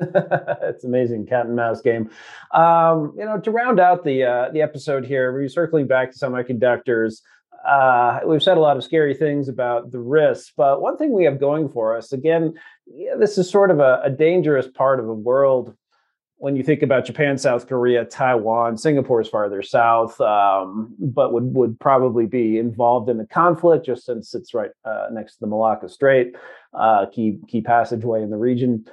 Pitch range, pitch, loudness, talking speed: 120-155 Hz, 130 Hz, -19 LUFS, 190 wpm